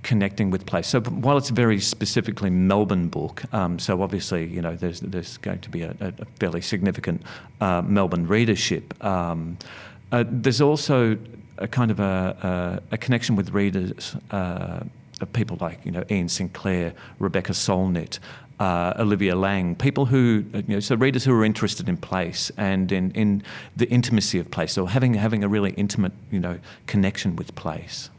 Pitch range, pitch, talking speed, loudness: 95-115 Hz, 100 Hz, 175 wpm, -24 LUFS